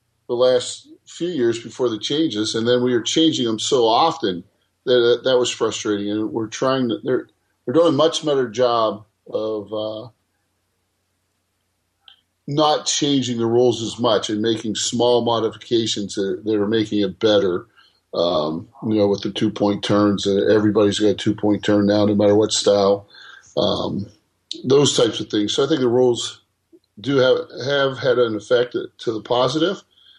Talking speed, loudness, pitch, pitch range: 175 wpm, -19 LUFS, 110 Hz, 105-125 Hz